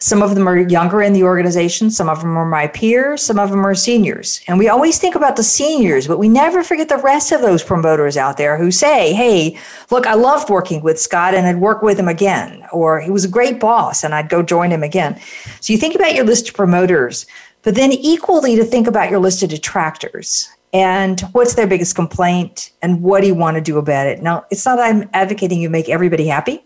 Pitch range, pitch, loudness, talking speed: 170-230 Hz, 195 Hz, -14 LUFS, 240 wpm